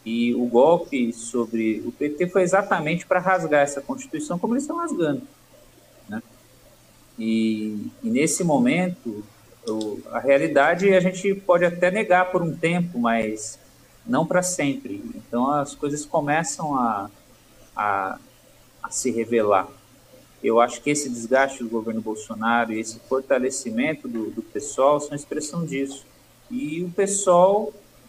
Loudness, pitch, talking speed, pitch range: -23 LUFS, 145 Hz, 140 wpm, 120-185 Hz